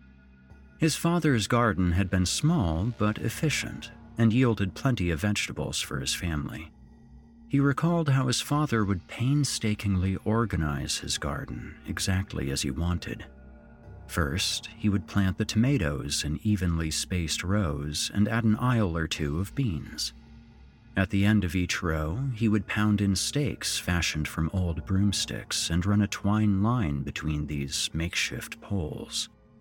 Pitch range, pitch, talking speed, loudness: 80-115 Hz, 100 Hz, 145 wpm, -28 LUFS